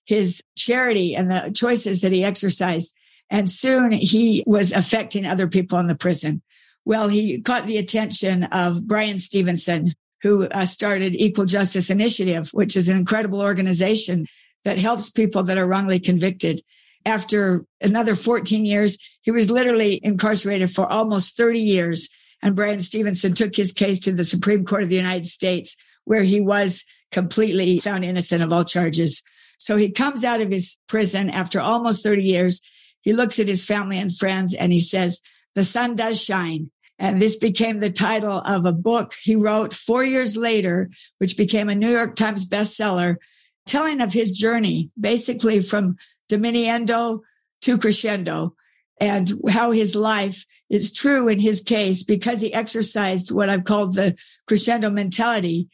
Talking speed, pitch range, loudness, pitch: 160 wpm, 185-220 Hz, -20 LUFS, 205 Hz